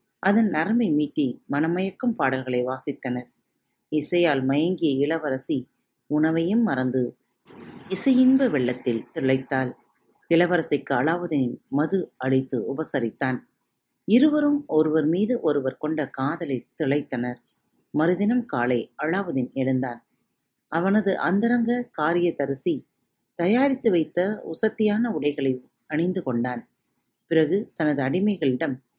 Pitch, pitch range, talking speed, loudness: 155 Hz, 130-195 Hz, 90 wpm, -24 LUFS